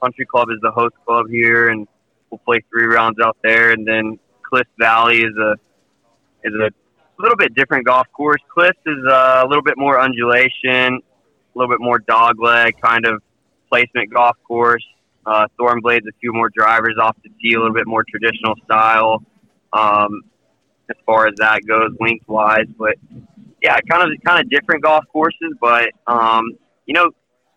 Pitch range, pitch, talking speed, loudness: 110-120 Hz, 115 Hz, 180 wpm, -14 LUFS